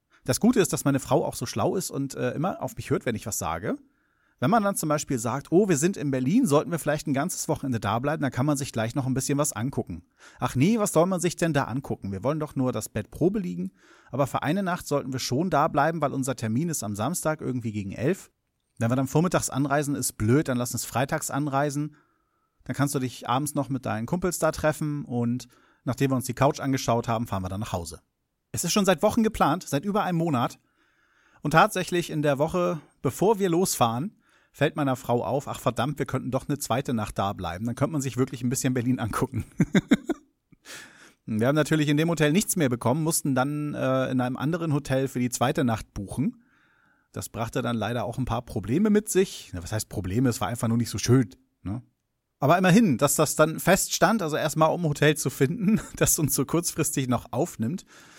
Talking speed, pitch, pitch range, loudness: 230 wpm, 140 Hz, 125-160 Hz, -26 LUFS